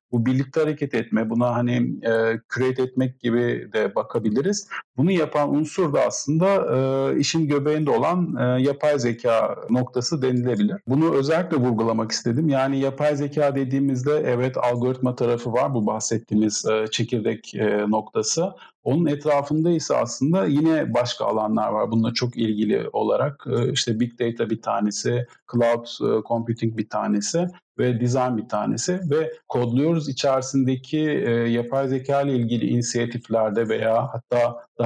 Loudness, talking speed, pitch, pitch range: -22 LUFS, 145 wpm, 125 Hz, 115-145 Hz